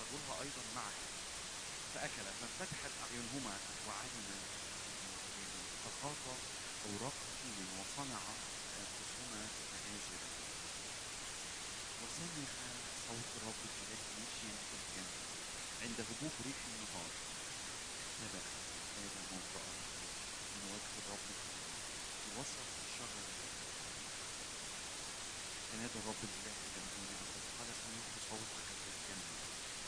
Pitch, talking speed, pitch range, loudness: 105 Hz, 70 wpm, 95-115 Hz, -44 LUFS